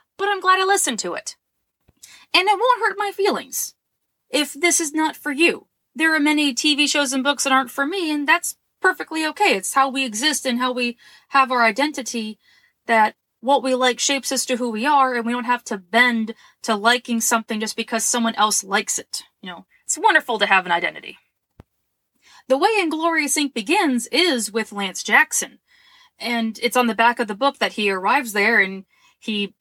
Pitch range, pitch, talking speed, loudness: 230-310 Hz, 260 Hz, 205 wpm, -19 LUFS